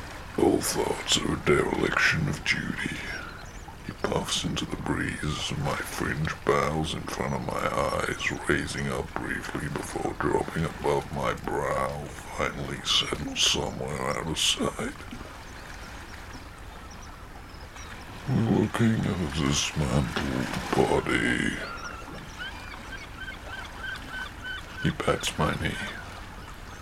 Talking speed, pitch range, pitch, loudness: 100 wpm, 75-95 Hz, 85 Hz, -28 LUFS